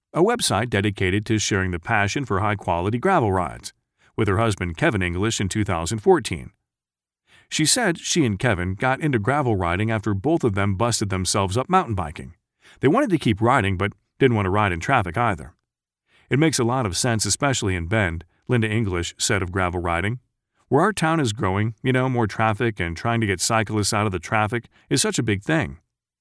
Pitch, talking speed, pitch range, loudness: 105 Hz, 200 wpm, 95-120 Hz, -22 LUFS